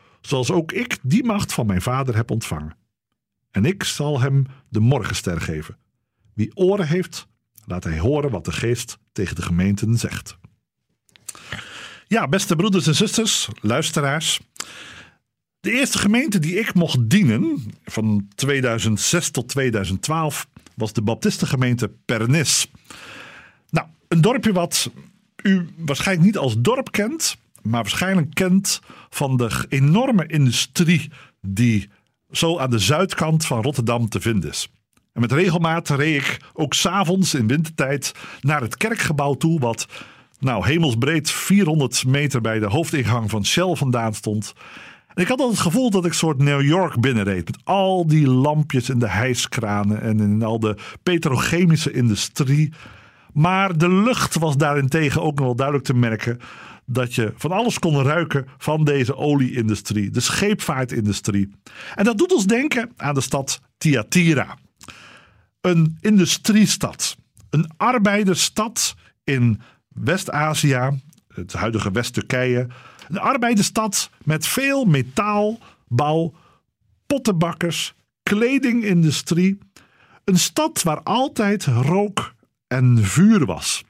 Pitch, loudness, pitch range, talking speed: 145 Hz, -20 LUFS, 120-180 Hz, 130 wpm